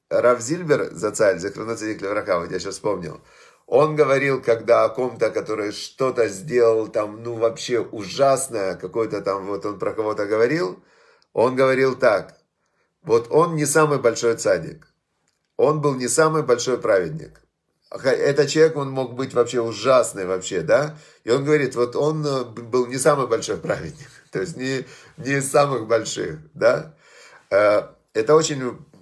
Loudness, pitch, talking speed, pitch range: -21 LUFS, 130 Hz, 150 wpm, 115-150 Hz